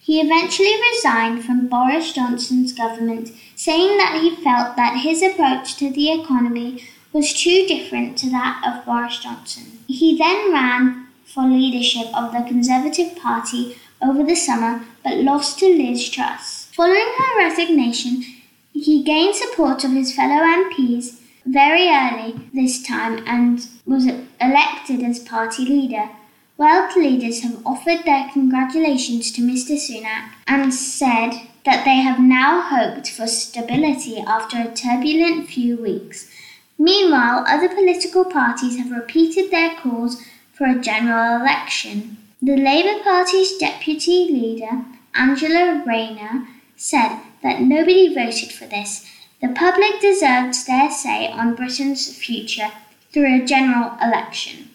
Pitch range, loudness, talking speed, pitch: 240-310 Hz, -17 LUFS, 135 wpm, 260 Hz